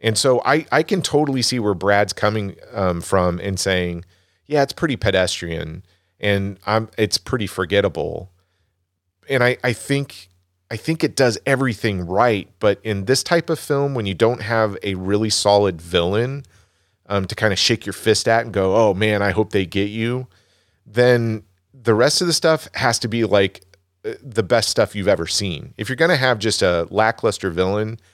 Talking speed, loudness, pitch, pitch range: 190 wpm, -19 LUFS, 105 Hz, 95-125 Hz